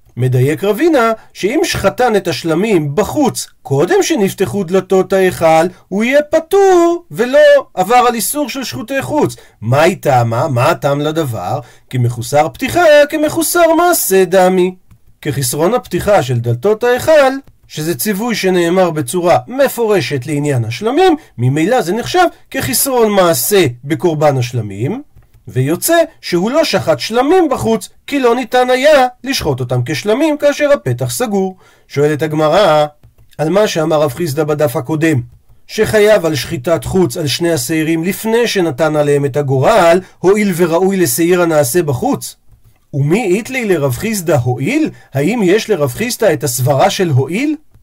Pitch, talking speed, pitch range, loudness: 180 Hz, 135 wpm, 150-245 Hz, -13 LUFS